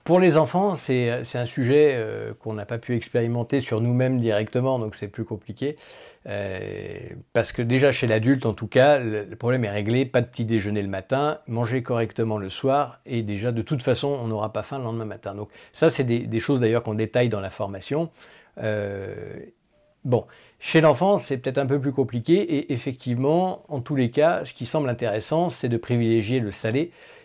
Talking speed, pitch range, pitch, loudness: 205 wpm, 110-140 Hz, 120 Hz, -24 LUFS